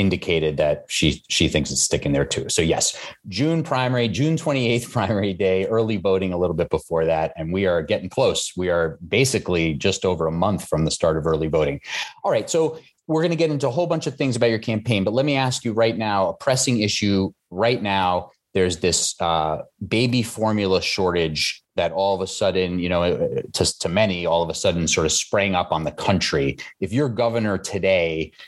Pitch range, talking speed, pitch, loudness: 90-120 Hz, 215 wpm, 100 Hz, -21 LUFS